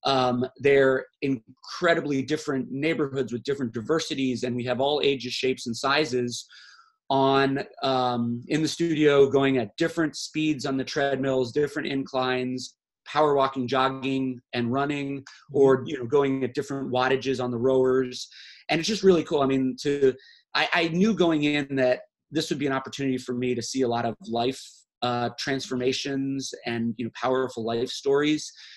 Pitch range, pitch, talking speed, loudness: 125-145 Hz, 135 Hz, 165 wpm, -25 LUFS